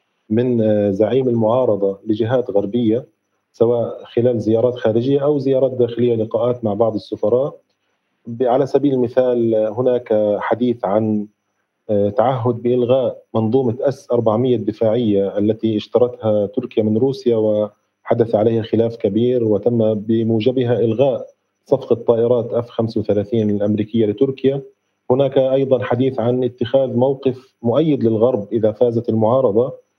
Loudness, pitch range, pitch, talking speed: -17 LUFS, 110-125 Hz, 115 Hz, 115 wpm